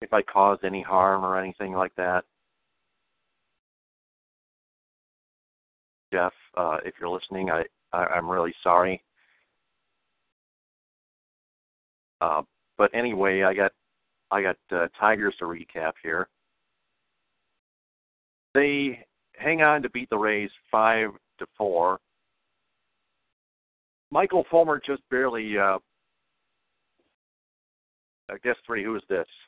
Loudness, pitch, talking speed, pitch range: -25 LUFS, 95 Hz, 105 wpm, 90-120 Hz